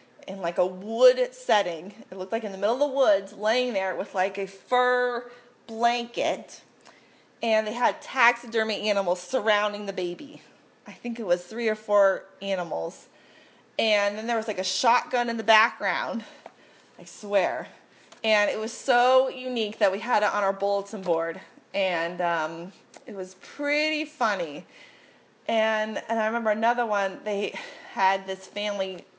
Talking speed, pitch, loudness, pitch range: 160 wpm, 215 Hz, -25 LUFS, 195-235 Hz